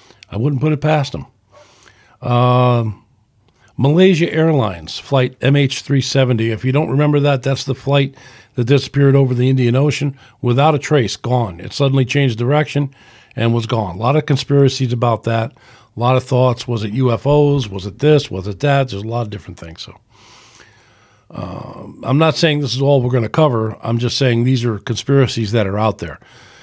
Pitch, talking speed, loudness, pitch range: 125 Hz, 185 wpm, -16 LUFS, 115-140 Hz